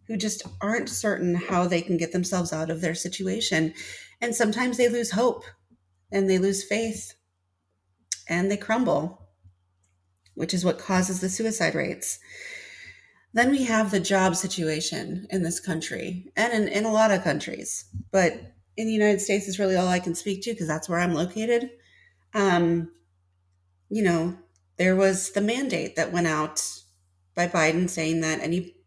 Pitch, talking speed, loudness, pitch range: 180 Hz, 165 wpm, -25 LUFS, 155-205 Hz